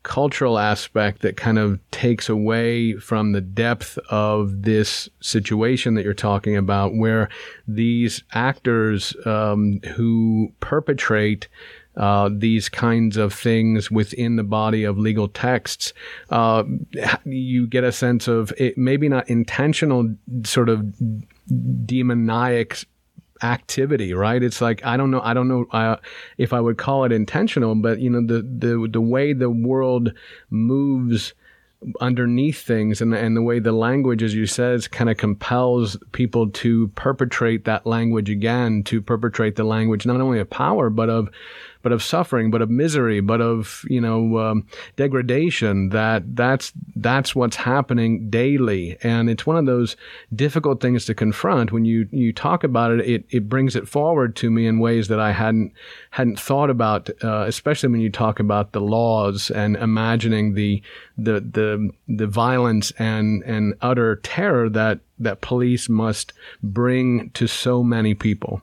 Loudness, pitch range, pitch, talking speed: -20 LUFS, 110-125 Hz, 115 Hz, 155 wpm